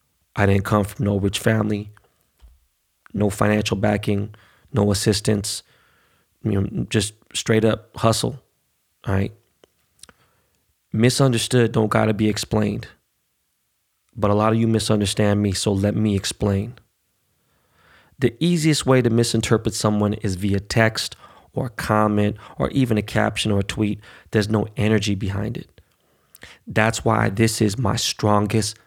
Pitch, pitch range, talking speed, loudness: 105 Hz, 100-115 Hz, 135 wpm, -21 LUFS